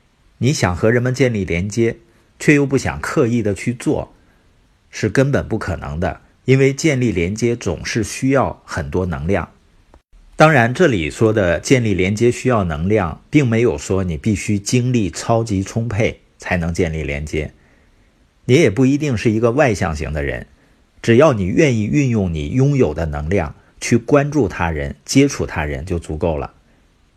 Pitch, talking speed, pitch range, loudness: 105 Hz, 245 characters per minute, 85-125 Hz, -17 LUFS